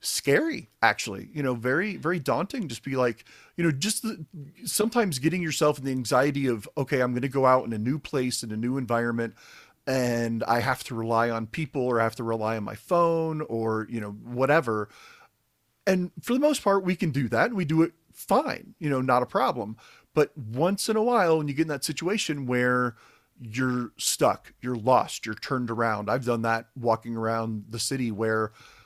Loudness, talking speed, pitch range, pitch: -26 LUFS, 210 wpm, 115-160 Hz, 130 Hz